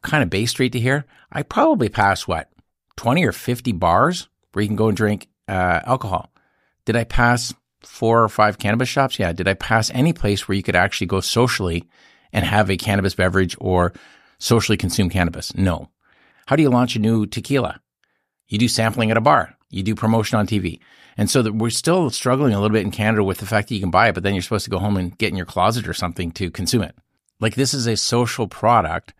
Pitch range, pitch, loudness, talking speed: 95-120 Hz, 105 Hz, -19 LUFS, 230 wpm